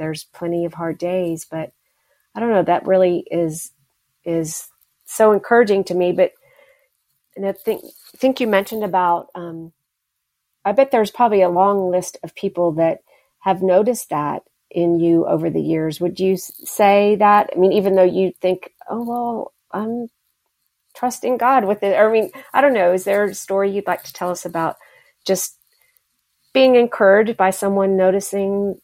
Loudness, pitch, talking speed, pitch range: -18 LUFS, 195 Hz, 175 wpm, 175-220 Hz